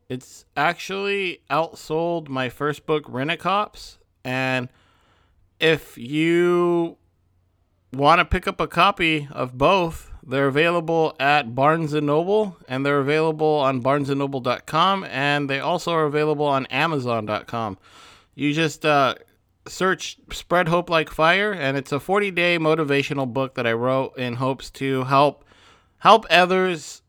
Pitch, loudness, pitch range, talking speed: 145 Hz, -21 LUFS, 130-165 Hz, 130 wpm